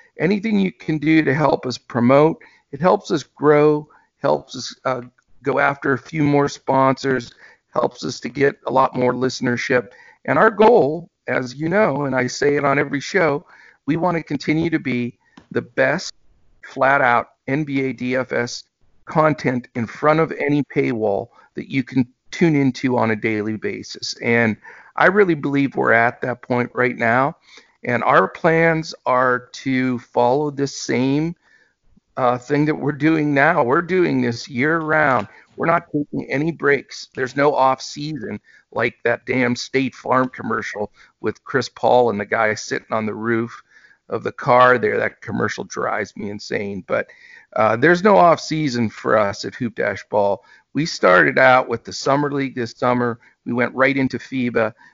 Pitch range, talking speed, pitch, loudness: 125-150 Hz, 175 wpm, 135 Hz, -19 LUFS